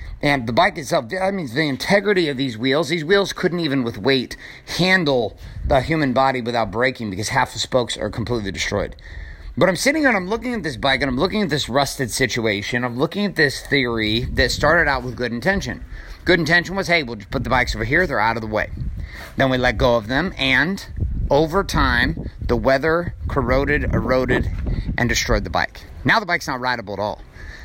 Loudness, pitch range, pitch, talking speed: -19 LUFS, 110-165 Hz, 130 Hz, 215 wpm